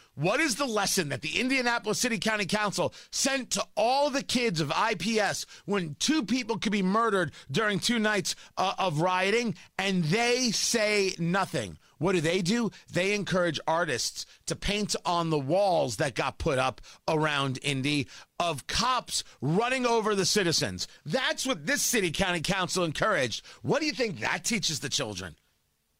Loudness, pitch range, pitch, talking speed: -28 LUFS, 170-230 Hz, 195 Hz, 165 wpm